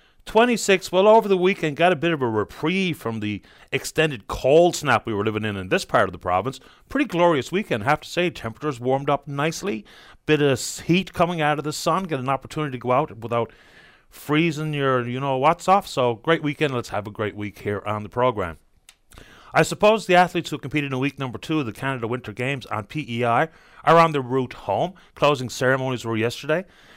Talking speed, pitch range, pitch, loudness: 215 wpm, 120-165 Hz, 140 Hz, -22 LUFS